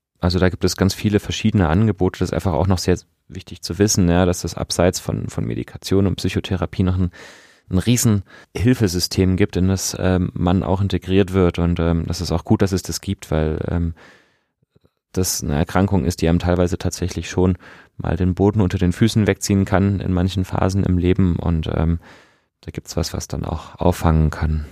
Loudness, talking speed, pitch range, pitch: -19 LUFS, 205 wpm, 85-95 Hz, 90 Hz